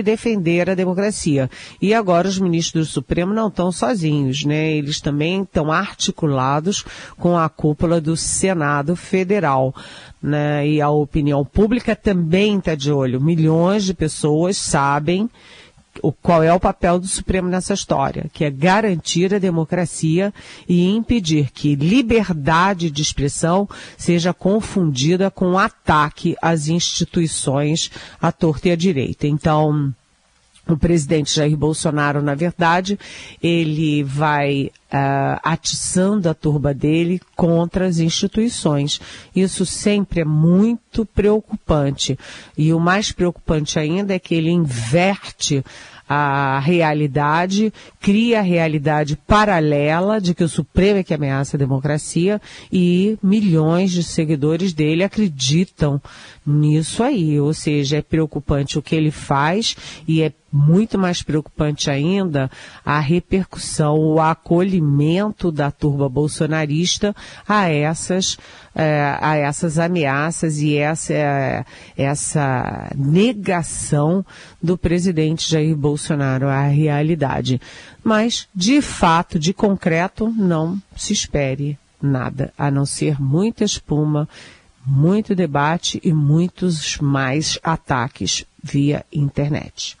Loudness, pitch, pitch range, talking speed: -18 LUFS, 165 Hz, 150-185 Hz, 120 wpm